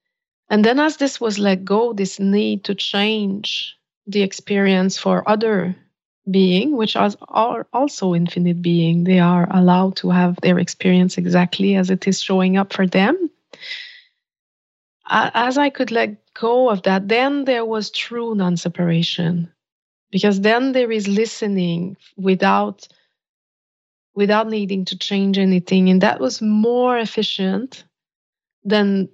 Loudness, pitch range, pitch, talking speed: -18 LUFS, 185-225 Hz, 195 Hz, 135 wpm